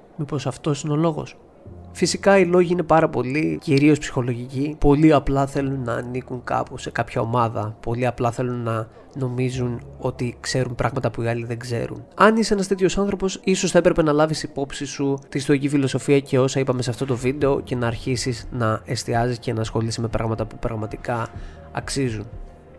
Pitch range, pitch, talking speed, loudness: 120-150 Hz, 130 Hz, 185 wpm, -22 LUFS